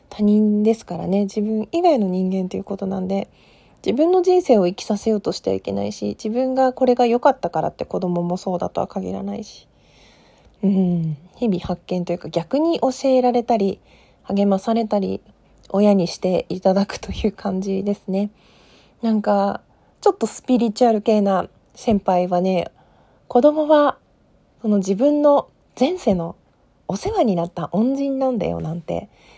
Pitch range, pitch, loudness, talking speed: 185-245 Hz, 205 Hz, -20 LUFS, 320 characters per minute